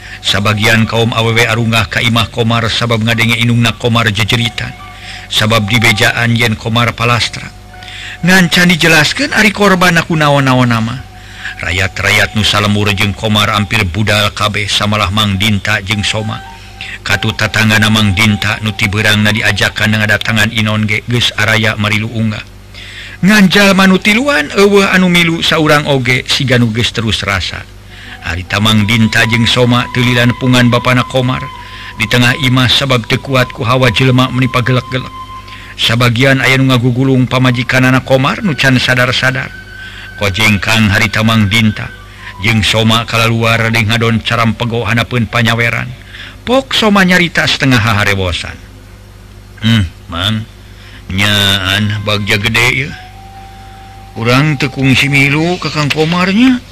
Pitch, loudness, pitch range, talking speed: 115 Hz, -10 LUFS, 105-130 Hz, 125 wpm